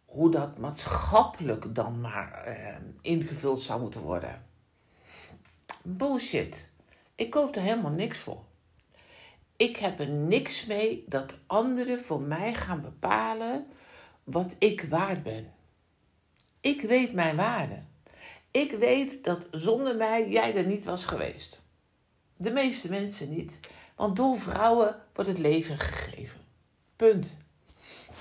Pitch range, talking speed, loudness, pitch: 155-230 Hz, 125 wpm, -29 LUFS, 195 Hz